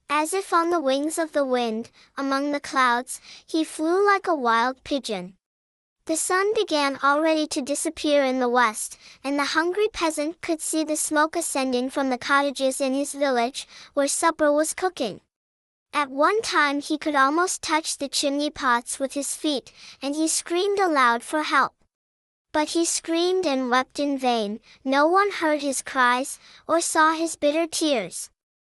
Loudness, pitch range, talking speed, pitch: -23 LUFS, 270-320 Hz, 170 wpm, 290 Hz